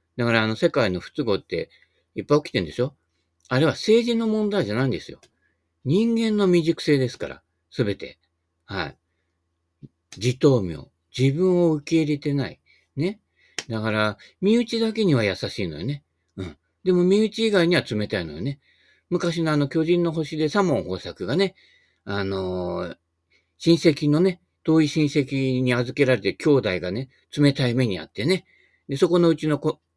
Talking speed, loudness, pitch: 310 characters per minute, -23 LUFS, 140 Hz